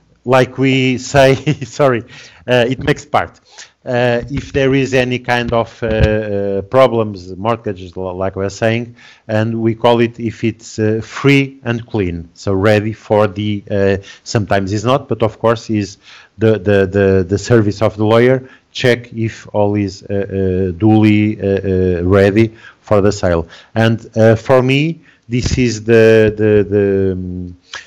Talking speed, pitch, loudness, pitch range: 165 wpm, 110 Hz, -14 LUFS, 100-120 Hz